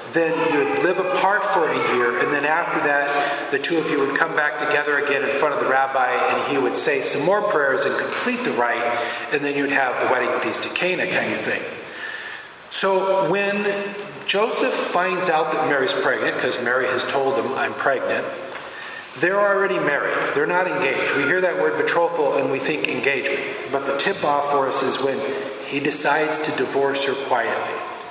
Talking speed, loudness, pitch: 195 wpm, -20 LUFS, 170 Hz